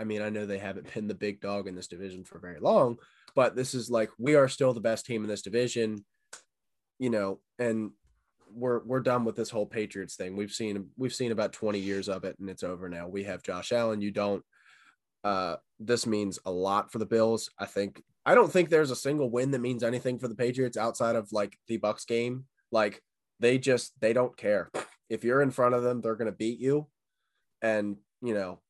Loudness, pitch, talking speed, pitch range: -30 LUFS, 110 Hz, 225 wpm, 100-125 Hz